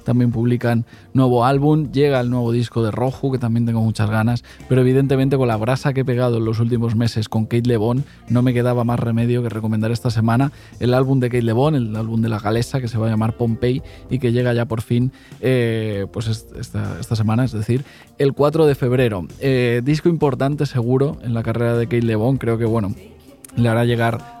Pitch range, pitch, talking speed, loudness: 115-130 Hz, 120 Hz, 225 wpm, -19 LUFS